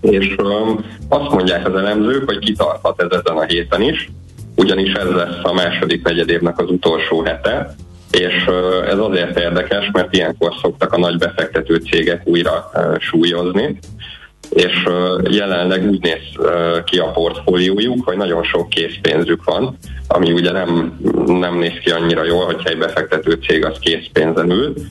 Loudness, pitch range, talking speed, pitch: -15 LUFS, 85-95 Hz, 150 wpm, 90 Hz